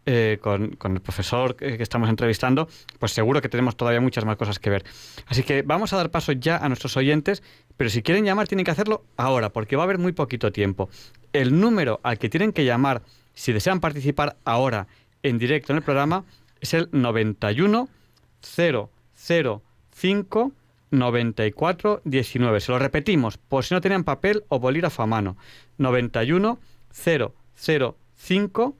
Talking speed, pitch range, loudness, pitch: 165 wpm, 115-165 Hz, -23 LUFS, 135 Hz